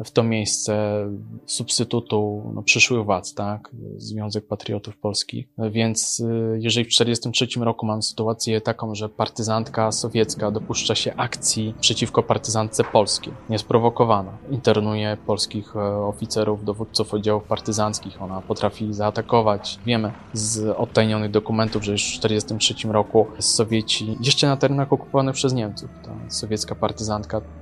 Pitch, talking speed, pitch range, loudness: 110 Hz, 125 wpm, 105-115 Hz, -22 LUFS